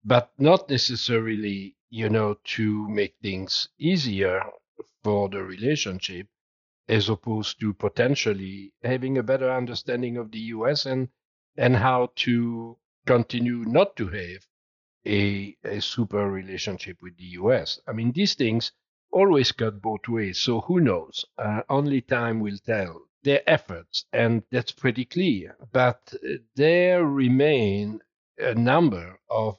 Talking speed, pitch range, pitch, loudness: 135 wpm, 105-130 Hz, 115 Hz, -24 LUFS